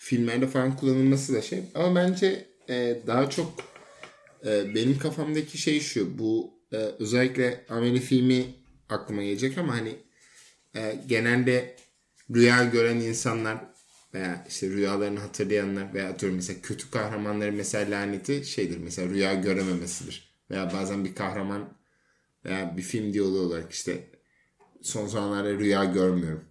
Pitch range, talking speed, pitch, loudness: 100-130 Hz, 130 wpm, 110 Hz, -27 LUFS